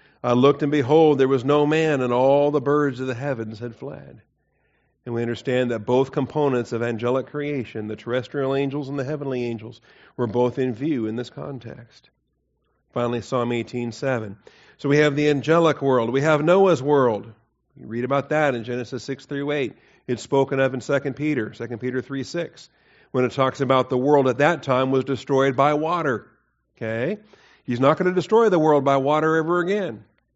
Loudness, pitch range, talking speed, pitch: -22 LUFS, 120-145 Hz, 195 wpm, 135 Hz